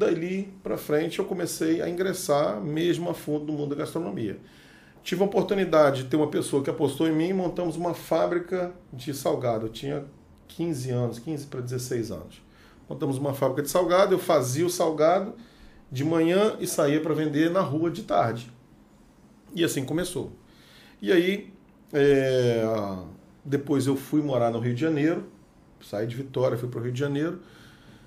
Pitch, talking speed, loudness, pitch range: 155 Hz, 175 wpm, -26 LUFS, 135-175 Hz